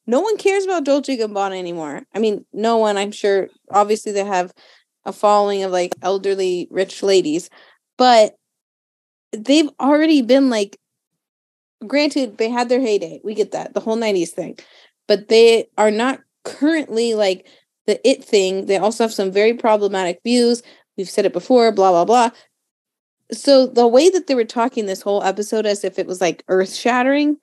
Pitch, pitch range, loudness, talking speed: 220 Hz, 195-255 Hz, -17 LUFS, 175 wpm